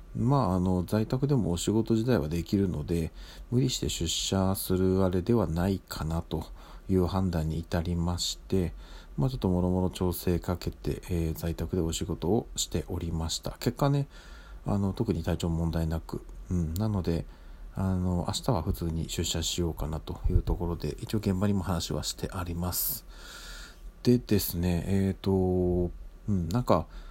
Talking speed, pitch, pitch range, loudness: 320 characters per minute, 90 Hz, 85-95 Hz, -30 LUFS